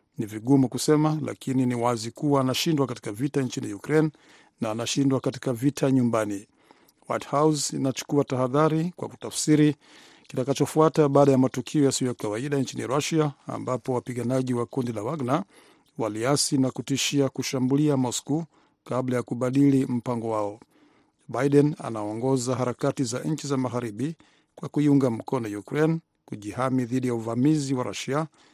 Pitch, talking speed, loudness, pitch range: 135 Hz, 135 wpm, -25 LUFS, 125-145 Hz